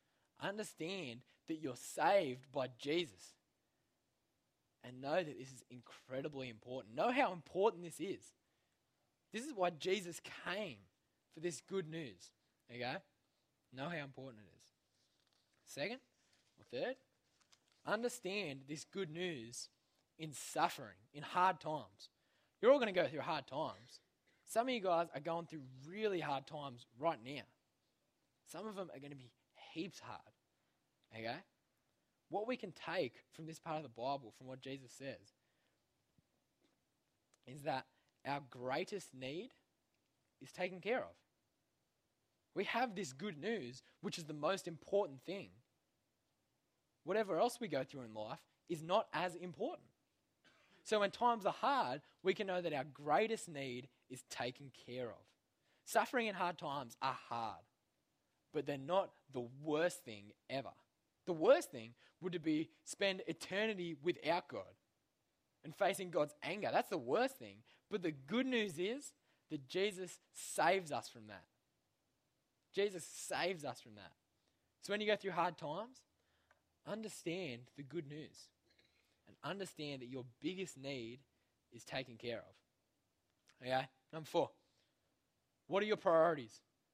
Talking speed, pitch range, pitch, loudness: 145 wpm, 130-185 Hz, 155 Hz, -41 LUFS